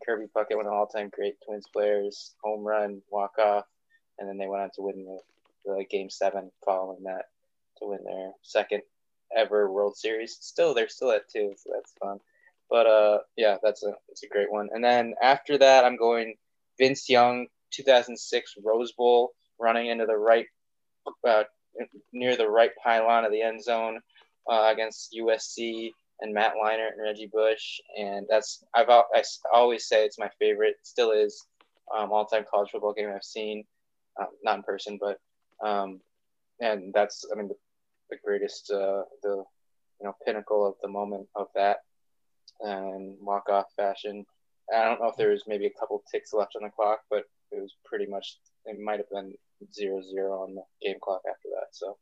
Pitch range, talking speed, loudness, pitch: 100-120 Hz, 185 wpm, -27 LUFS, 110 Hz